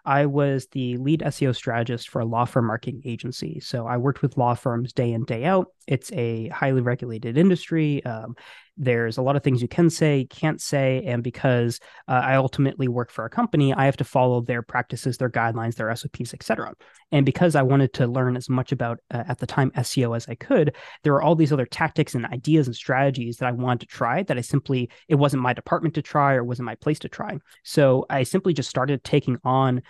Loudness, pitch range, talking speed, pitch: -23 LUFS, 120-145 Hz, 225 wpm, 130 Hz